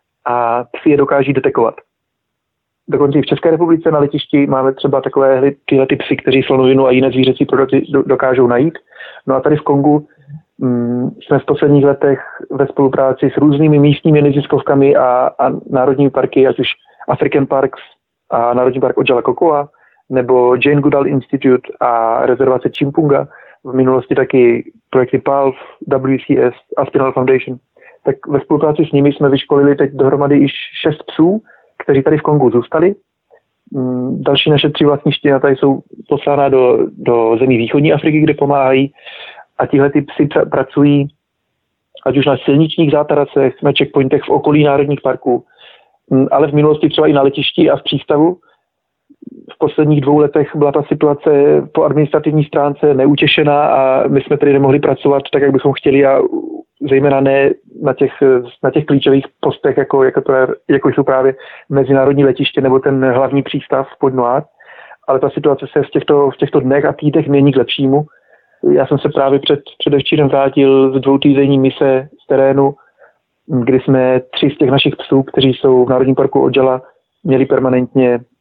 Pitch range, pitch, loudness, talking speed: 135-145 Hz, 140 Hz, -12 LUFS, 165 wpm